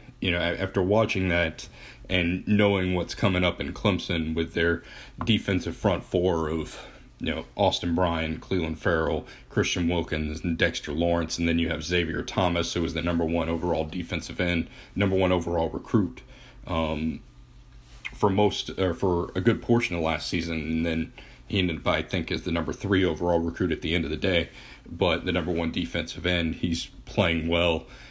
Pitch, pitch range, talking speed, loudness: 85 Hz, 80-95 Hz, 185 wpm, -26 LUFS